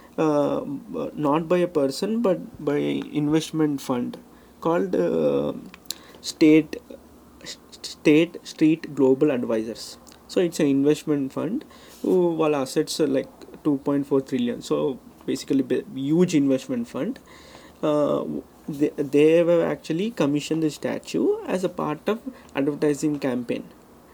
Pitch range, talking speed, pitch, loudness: 145-170 Hz, 120 wpm, 150 Hz, -23 LUFS